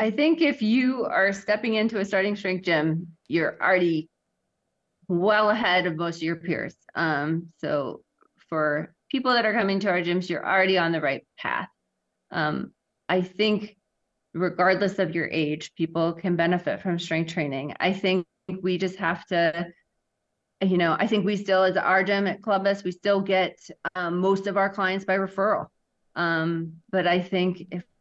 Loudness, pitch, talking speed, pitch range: -25 LUFS, 185 Hz, 175 wpm, 170-200 Hz